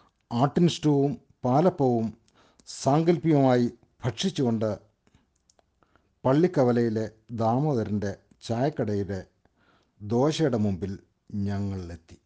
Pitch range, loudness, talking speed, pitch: 105-140 Hz, -26 LUFS, 50 wpm, 120 Hz